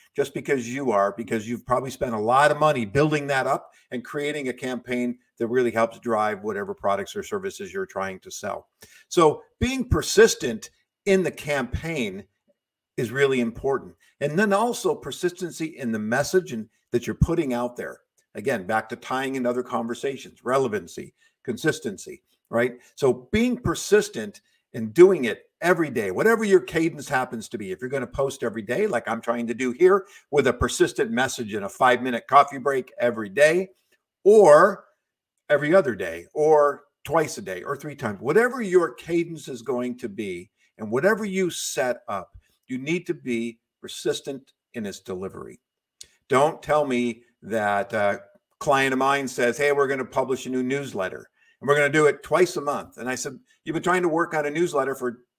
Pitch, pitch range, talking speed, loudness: 140 Hz, 120-180 Hz, 185 wpm, -24 LUFS